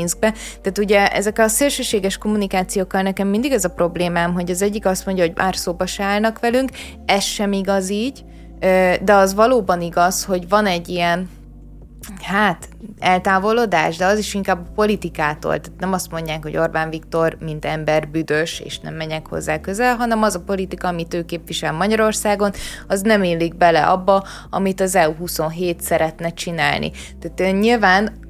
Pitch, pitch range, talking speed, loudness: 185 Hz, 170-205 Hz, 165 wpm, -18 LUFS